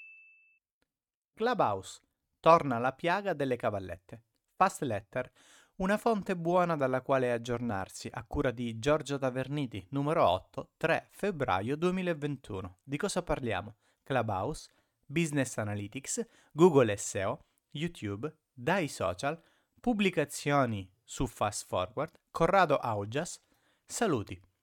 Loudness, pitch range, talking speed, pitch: -32 LUFS, 120-170 Hz, 100 wpm, 140 Hz